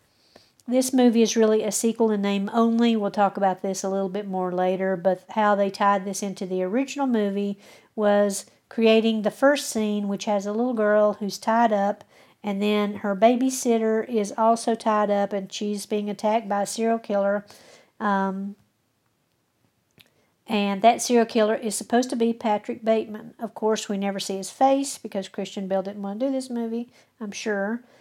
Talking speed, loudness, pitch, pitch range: 180 wpm, -23 LUFS, 210 Hz, 200-230 Hz